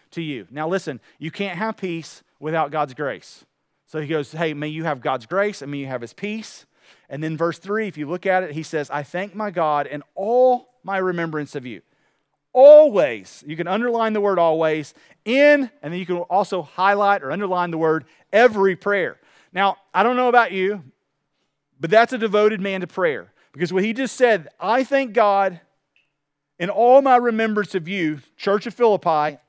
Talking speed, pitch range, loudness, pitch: 195 wpm, 155-210 Hz, -20 LUFS, 185 Hz